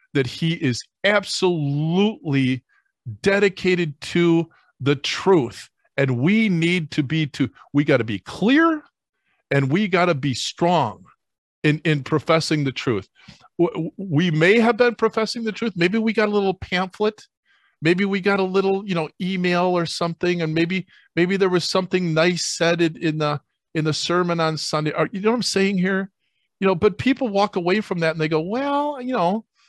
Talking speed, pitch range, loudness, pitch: 180 wpm, 155-200 Hz, -21 LUFS, 175 Hz